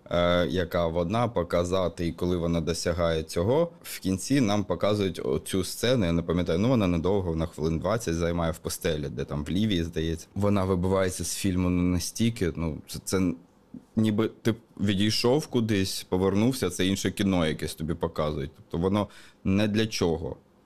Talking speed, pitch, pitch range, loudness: 155 wpm, 90 Hz, 85-100 Hz, -27 LUFS